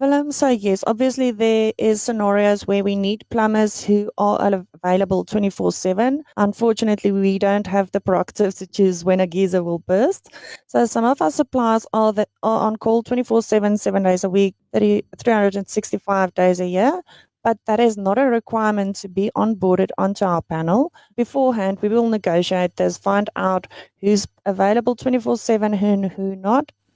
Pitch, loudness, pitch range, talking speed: 205 Hz, -19 LUFS, 195-230 Hz, 165 wpm